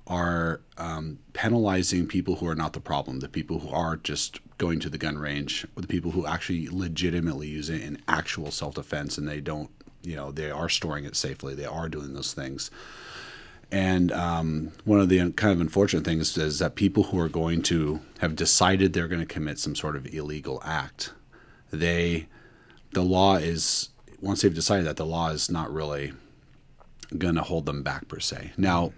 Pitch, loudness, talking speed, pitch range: 85 Hz, -27 LUFS, 195 wpm, 75-90 Hz